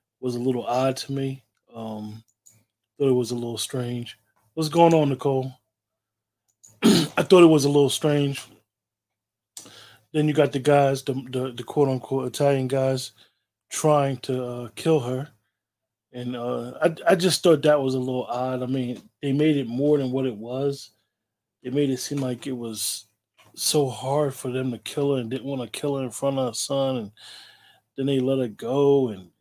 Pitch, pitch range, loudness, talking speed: 130 Hz, 115-140 Hz, -23 LUFS, 190 wpm